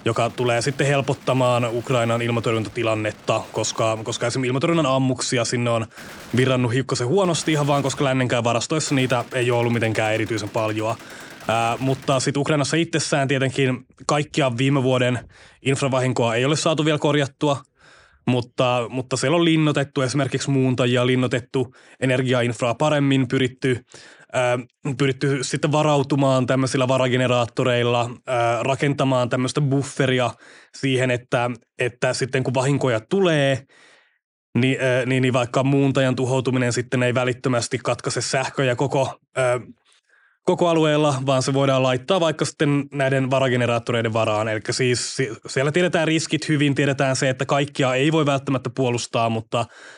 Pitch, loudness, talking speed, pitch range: 130 Hz, -21 LUFS, 130 wpm, 120-140 Hz